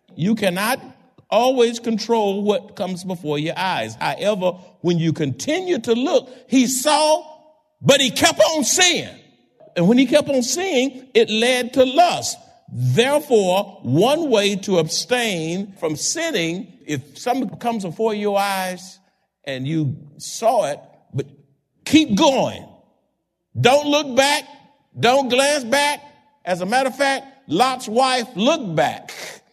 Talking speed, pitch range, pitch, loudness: 135 wpm, 185-280 Hz, 235 Hz, -19 LUFS